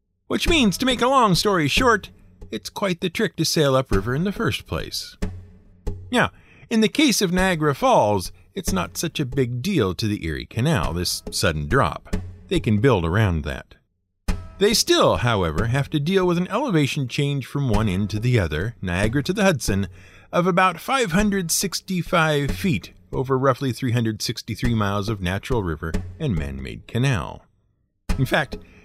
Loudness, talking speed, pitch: -22 LUFS, 170 wpm, 120 Hz